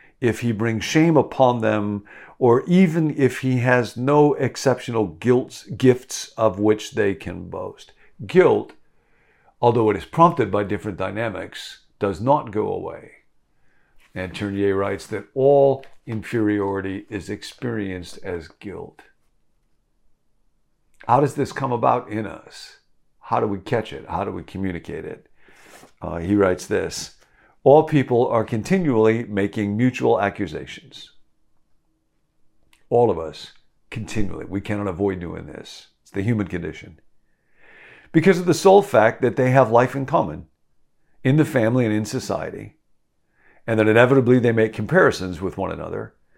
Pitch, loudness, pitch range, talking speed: 110 Hz, -20 LUFS, 100-130 Hz, 140 wpm